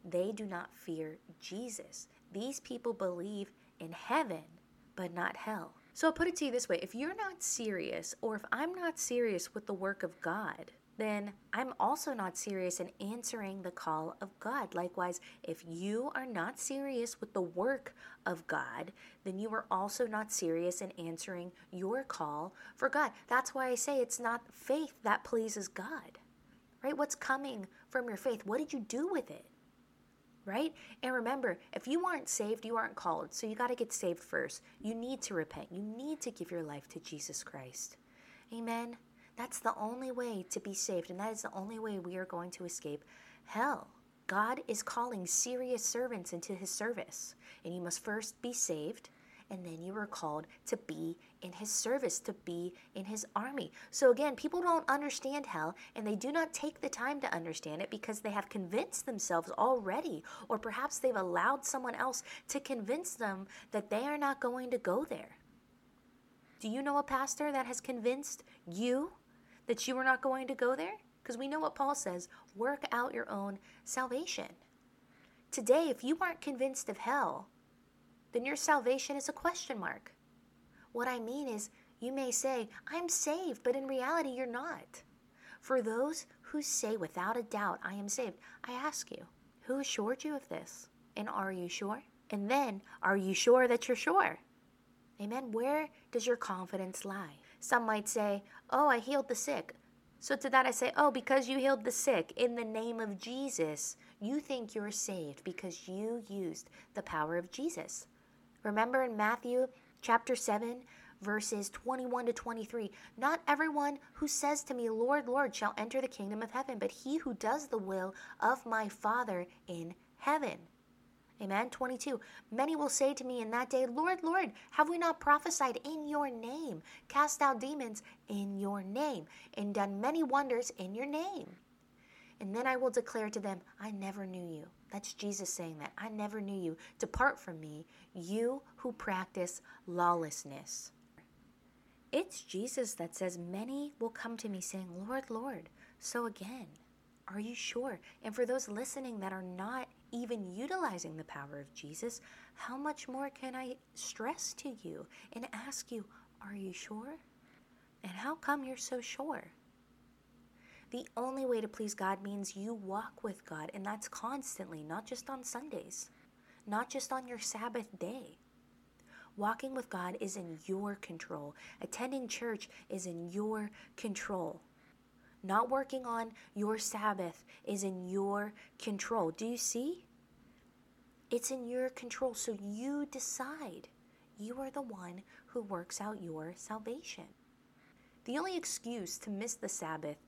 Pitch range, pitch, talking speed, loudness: 200-265 Hz, 235 Hz, 175 wpm, -37 LUFS